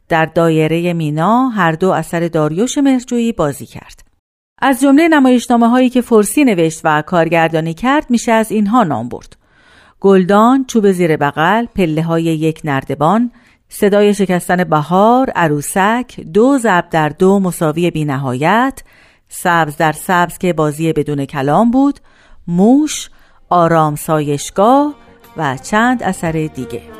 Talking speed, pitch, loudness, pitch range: 130 wpm, 180 Hz, -13 LUFS, 160-230 Hz